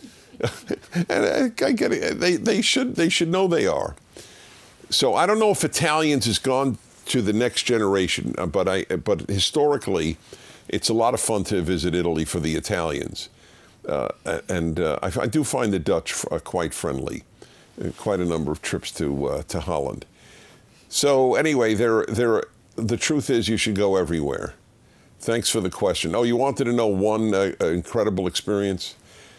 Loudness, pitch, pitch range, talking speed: -23 LUFS, 110 Hz, 95-145 Hz, 170 wpm